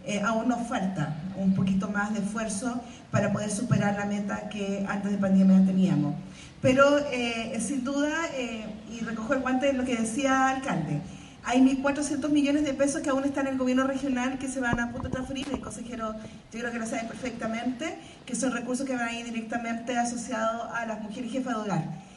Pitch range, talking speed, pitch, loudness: 205-265 Hz, 210 wpm, 235 Hz, -28 LUFS